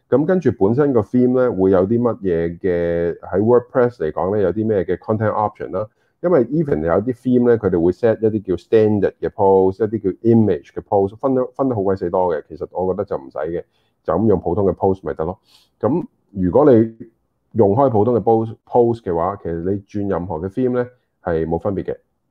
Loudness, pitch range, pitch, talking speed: -18 LUFS, 95-125 Hz, 110 Hz, 445 characters per minute